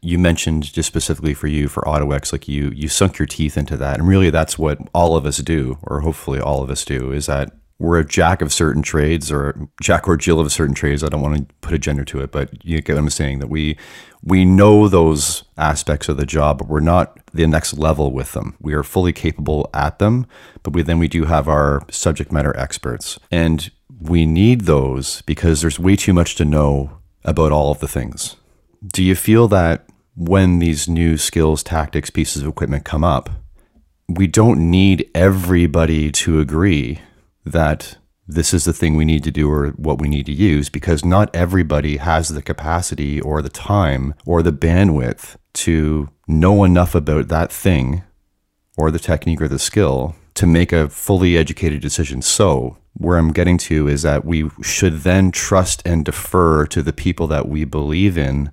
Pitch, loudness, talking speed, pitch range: 80 Hz, -17 LUFS, 200 wpm, 75-85 Hz